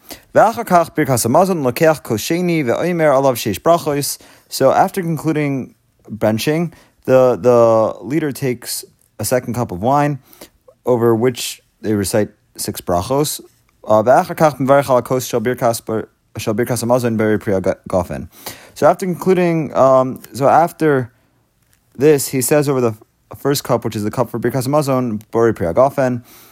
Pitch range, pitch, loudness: 115-150 Hz, 125 Hz, -16 LUFS